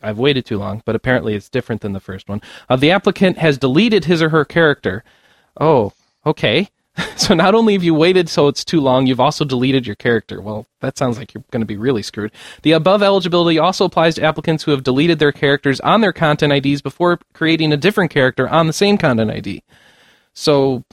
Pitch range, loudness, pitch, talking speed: 125-165 Hz, -15 LUFS, 145 Hz, 215 wpm